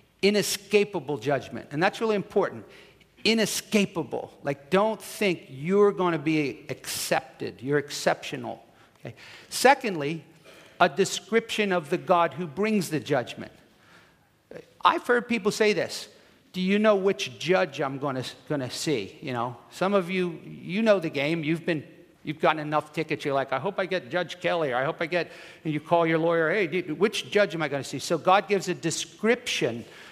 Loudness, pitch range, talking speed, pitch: -26 LUFS, 150-200 Hz, 180 wpm, 170 Hz